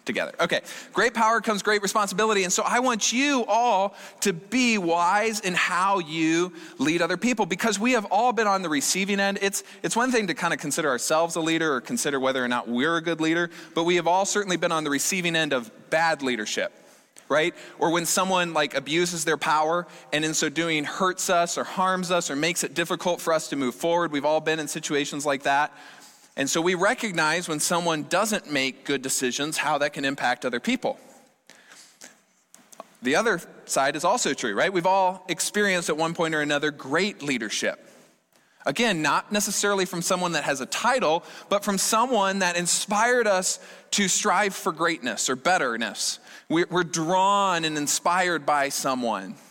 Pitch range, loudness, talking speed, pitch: 155-200 Hz, -24 LUFS, 190 wpm, 175 Hz